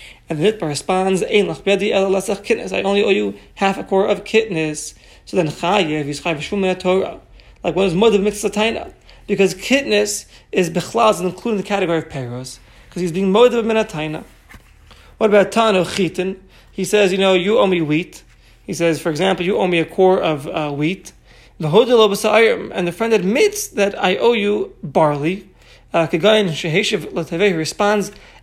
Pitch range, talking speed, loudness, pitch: 170-210 Hz, 160 wpm, -17 LUFS, 190 Hz